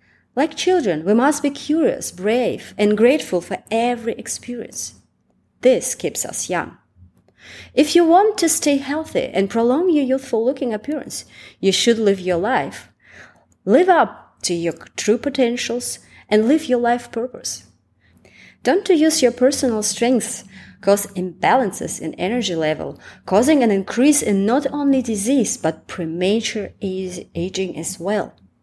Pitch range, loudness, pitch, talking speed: 195-280 Hz, -19 LUFS, 235 Hz, 145 wpm